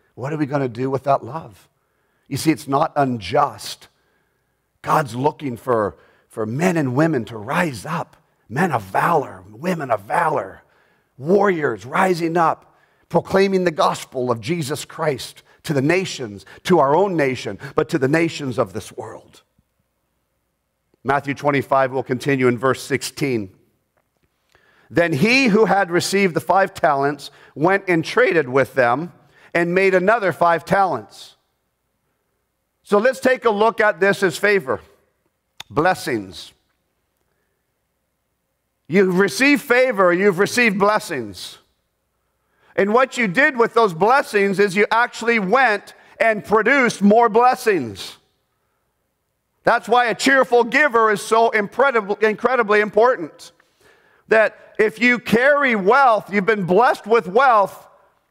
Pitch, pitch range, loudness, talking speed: 190 Hz, 145-220 Hz, -18 LUFS, 130 wpm